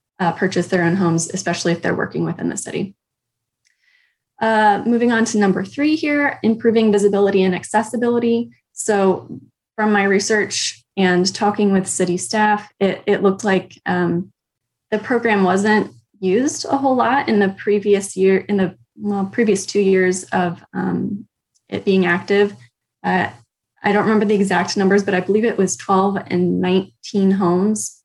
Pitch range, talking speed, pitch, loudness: 185-215 Hz, 160 wpm, 200 Hz, -18 LUFS